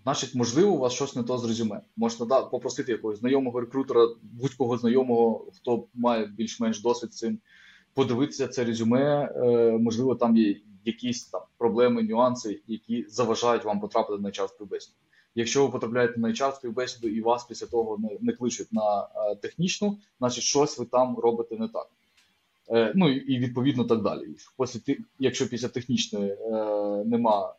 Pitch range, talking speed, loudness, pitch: 115-130 Hz, 165 wpm, -26 LUFS, 120 Hz